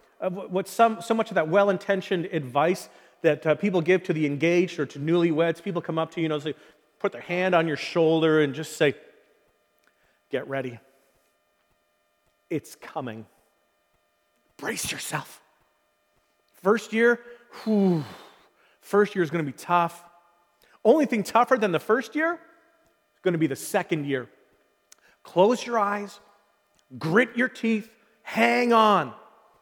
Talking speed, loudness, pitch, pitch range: 150 wpm, -25 LUFS, 175 Hz, 150-215 Hz